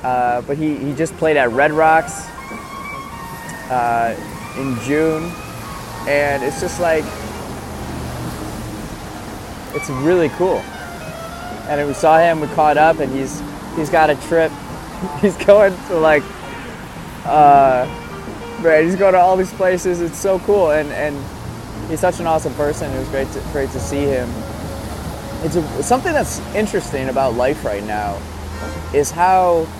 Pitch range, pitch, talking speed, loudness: 125-160 Hz, 145 Hz, 145 wpm, -17 LUFS